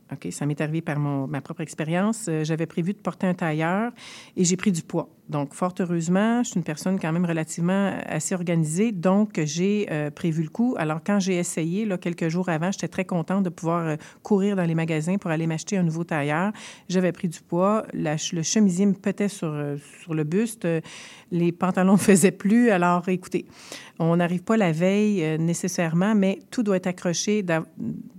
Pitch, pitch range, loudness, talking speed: 180 Hz, 165-195 Hz, -24 LUFS, 200 wpm